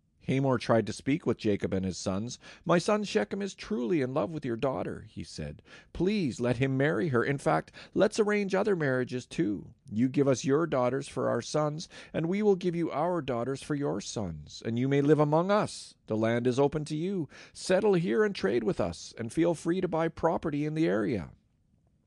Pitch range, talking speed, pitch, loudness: 120-175 Hz, 210 wpm, 145 Hz, -29 LUFS